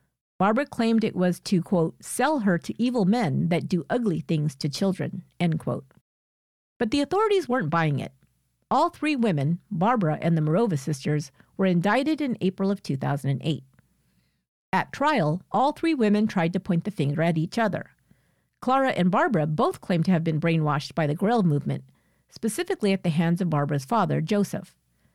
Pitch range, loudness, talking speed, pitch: 155-220 Hz, -25 LUFS, 175 wpm, 180 Hz